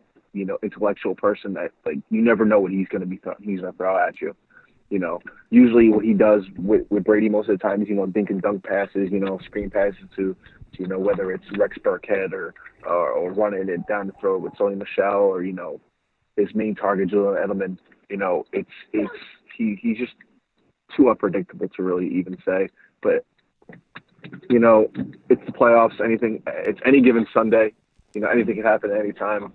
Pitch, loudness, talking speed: 110 Hz, -21 LUFS, 205 wpm